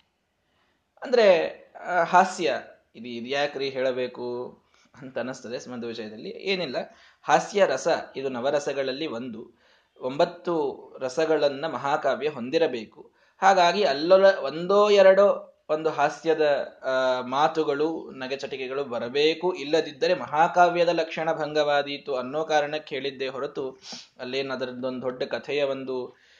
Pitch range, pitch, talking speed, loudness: 130-165 Hz, 145 Hz, 95 wpm, -25 LUFS